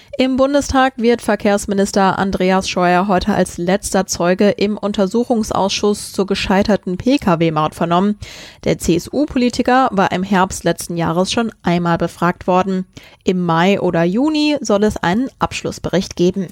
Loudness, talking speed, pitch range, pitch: -16 LUFS, 130 wpm, 180-215 Hz, 195 Hz